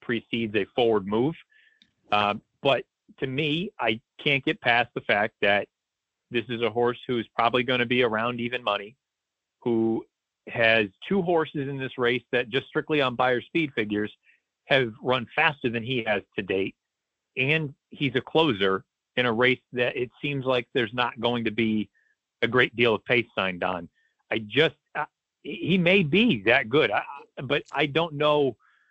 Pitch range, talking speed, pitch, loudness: 115-145 Hz, 175 wpm, 125 Hz, -25 LUFS